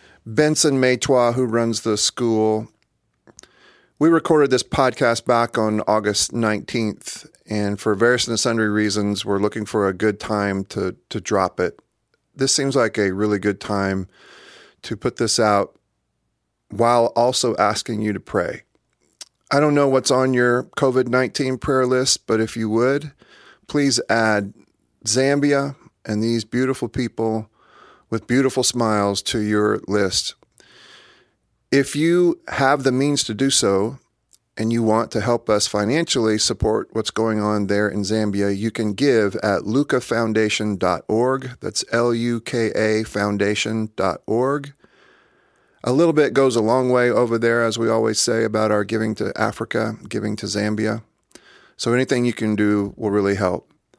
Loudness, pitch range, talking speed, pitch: -20 LUFS, 105-130 Hz, 150 wpm, 115 Hz